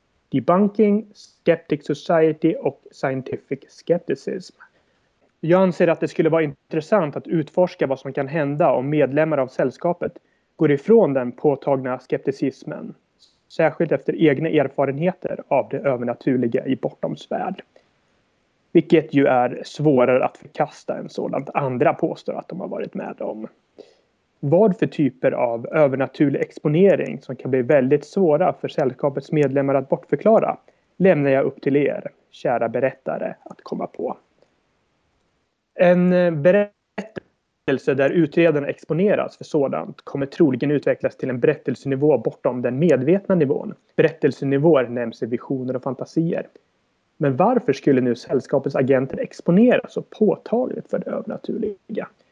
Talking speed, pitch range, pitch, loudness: 130 wpm, 135-175 Hz, 150 Hz, -21 LUFS